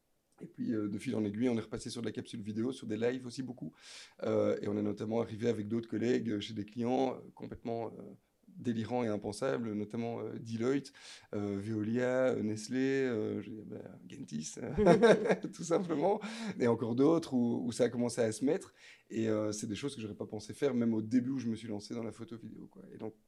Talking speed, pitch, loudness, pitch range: 220 wpm, 115 Hz, -34 LUFS, 110-125 Hz